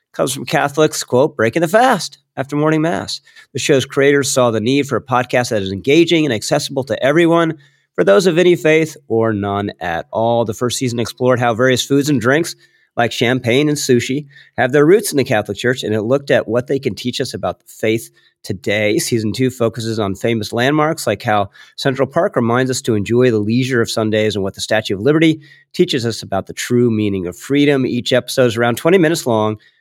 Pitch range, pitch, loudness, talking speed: 110-145 Hz, 125 Hz, -16 LUFS, 215 wpm